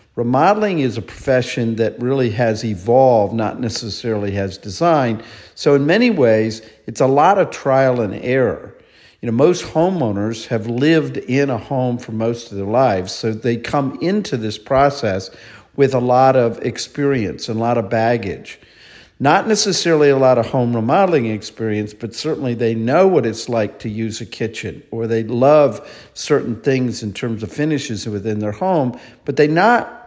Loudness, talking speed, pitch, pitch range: -17 LUFS, 175 wpm, 120 Hz, 110-140 Hz